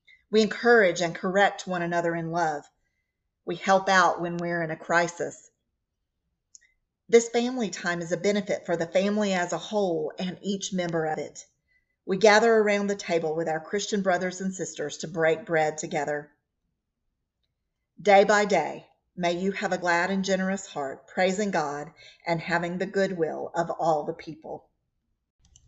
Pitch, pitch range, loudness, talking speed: 180 Hz, 165-195 Hz, -26 LUFS, 165 wpm